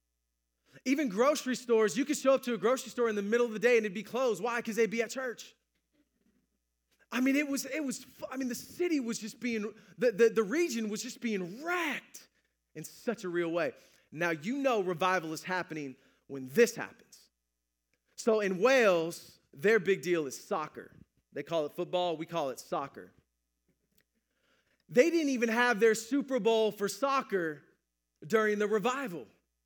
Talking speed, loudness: 180 wpm, -31 LUFS